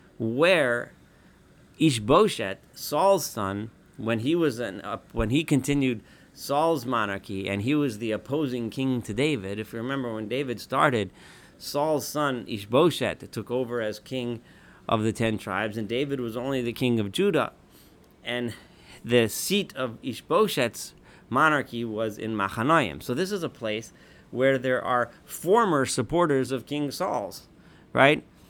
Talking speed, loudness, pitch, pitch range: 145 wpm, -26 LUFS, 120 Hz, 110-140 Hz